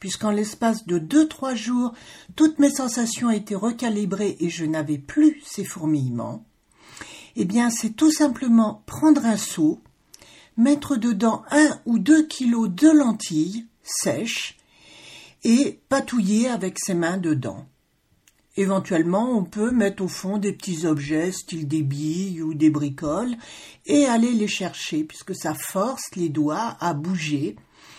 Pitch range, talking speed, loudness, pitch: 165-240 Hz, 140 wpm, -22 LUFS, 205 Hz